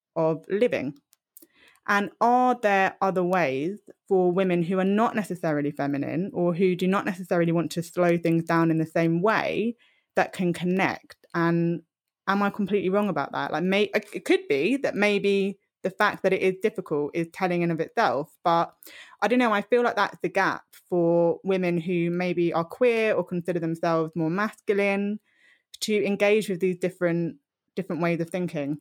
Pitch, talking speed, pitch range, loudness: 185 Hz, 175 wpm, 170-205 Hz, -25 LUFS